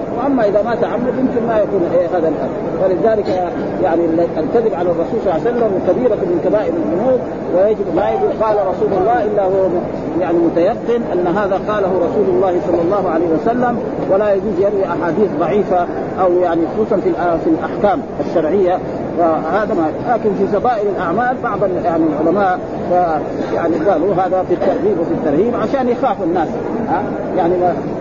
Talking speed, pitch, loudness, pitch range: 160 wpm, 190 Hz, -16 LUFS, 175-220 Hz